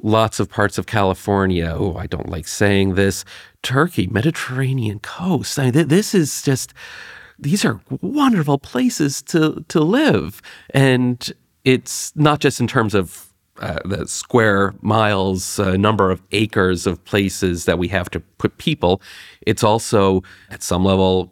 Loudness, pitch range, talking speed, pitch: -18 LUFS, 95-130 Hz, 155 wpm, 105 Hz